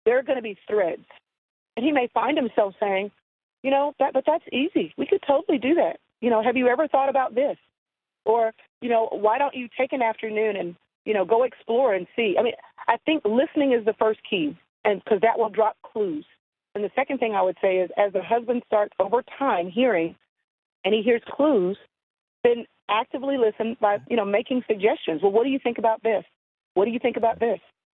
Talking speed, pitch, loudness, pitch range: 220 wpm, 235 Hz, -24 LUFS, 215-270 Hz